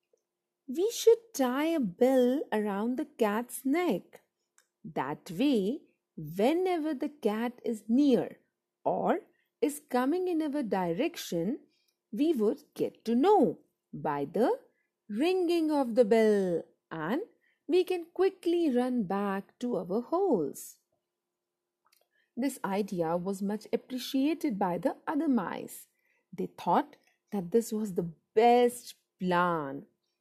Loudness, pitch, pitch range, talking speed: -30 LUFS, 250 Hz, 210-315 Hz, 115 wpm